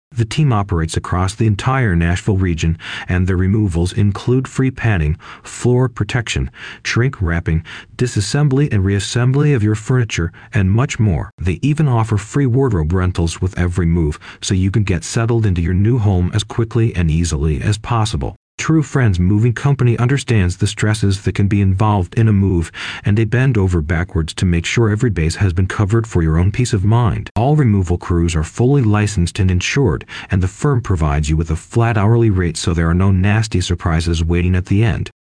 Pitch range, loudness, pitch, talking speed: 90-115 Hz, -16 LUFS, 105 Hz, 190 wpm